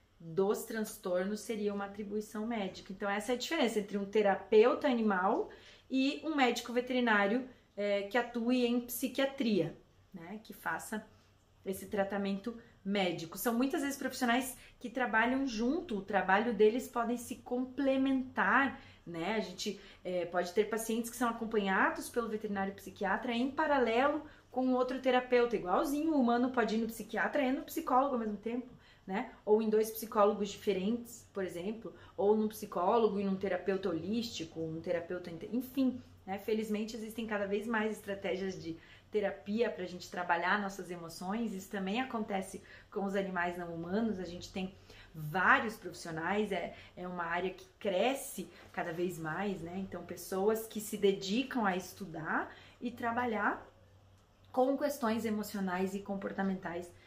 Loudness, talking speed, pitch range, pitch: -34 LUFS, 150 wpm, 190-240 Hz, 215 Hz